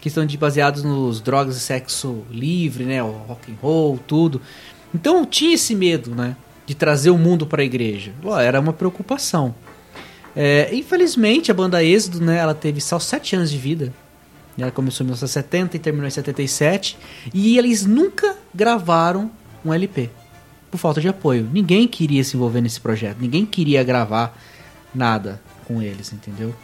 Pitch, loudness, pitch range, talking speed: 145 Hz, -19 LUFS, 125-175 Hz, 170 wpm